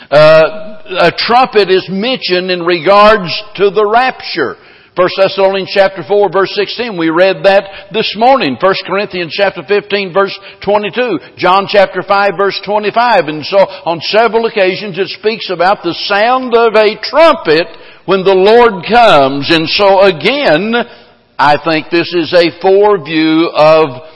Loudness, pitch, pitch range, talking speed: -10 LUFS, 195 Hz, 180-210 Hz, 145 wpm